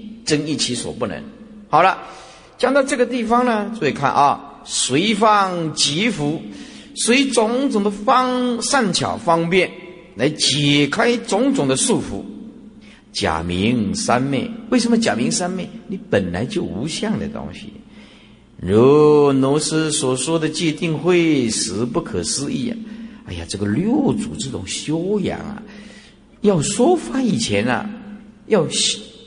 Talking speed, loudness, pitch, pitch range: 190 characters per minute, -18 LUFS, 210 Hz, 155-230 Hz